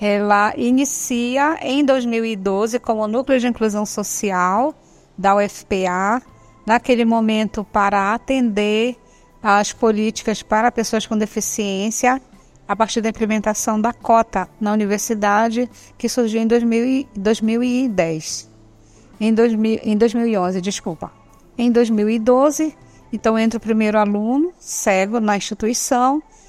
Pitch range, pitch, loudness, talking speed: 210-240 Hz, 220 Hz, -18 LUFS, 110 wpm